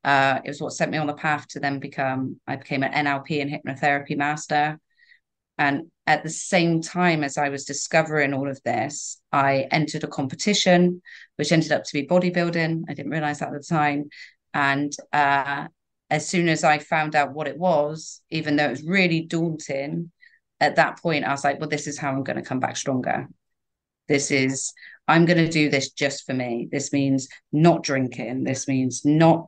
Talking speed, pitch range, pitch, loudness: 200 wpm, 140-160 Hz, 150 Hz, -23 LUFS